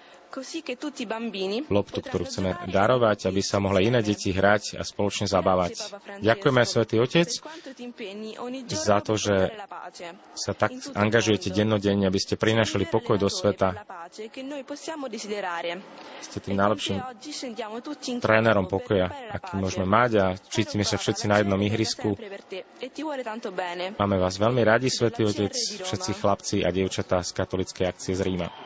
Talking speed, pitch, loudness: 125 wpm, 110 Hz, -25 LUFS